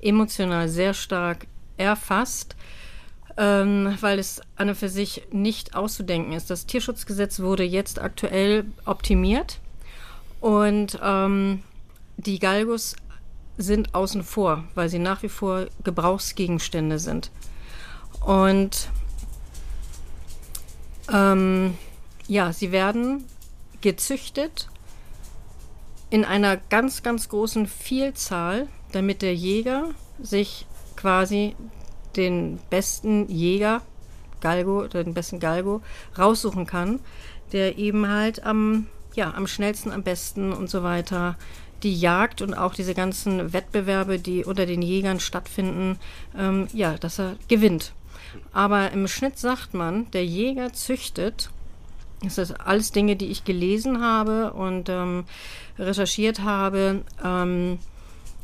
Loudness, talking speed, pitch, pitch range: -24 LUFS, 115 wpm, 195 Hz, 180-210 Hz